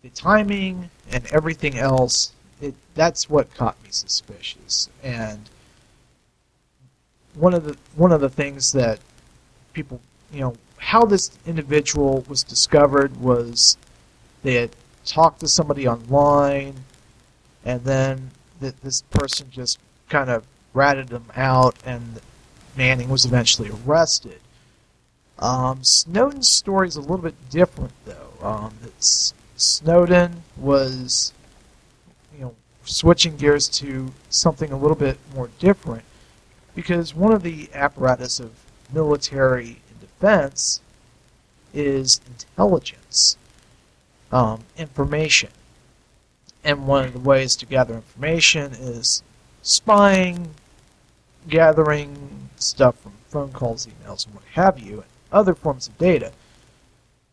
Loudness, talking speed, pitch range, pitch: -19 LUFS, 120 wpm, 125-155 Hz, 135 Hz